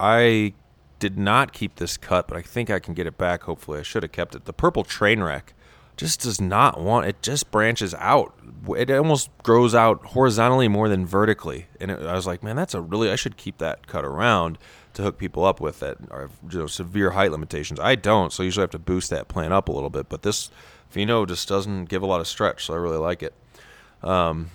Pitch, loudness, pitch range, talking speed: 95 Hz, -22 LUFS, 85-115 Hz, 240 wpm